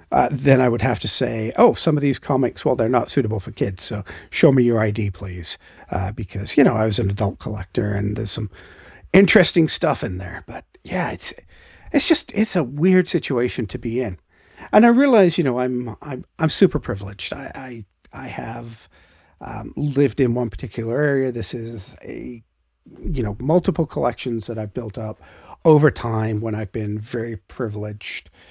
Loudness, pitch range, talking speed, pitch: -20 LUFS, 105-140 Hz, 190 wpm, 115 Hz